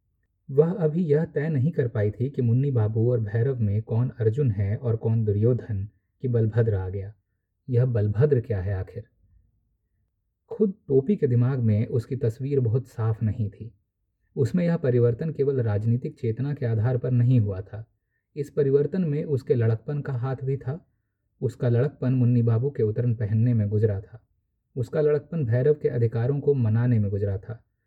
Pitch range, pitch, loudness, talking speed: 105-135 Hz, 120 Hz, -25 LUFS, 175 wpm